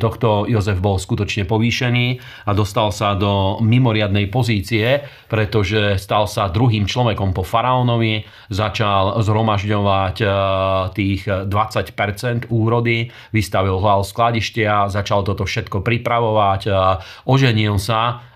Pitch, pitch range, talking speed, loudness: 110 Hz, 100-115 Hz, 105 wpm, -18 LUFS